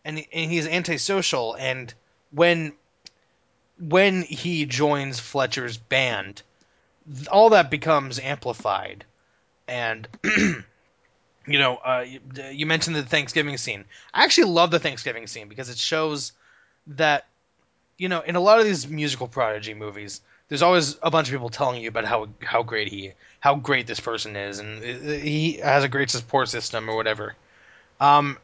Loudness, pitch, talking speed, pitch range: -22 LUFS, 140 Hz, 155 wpm, 120-155 Hz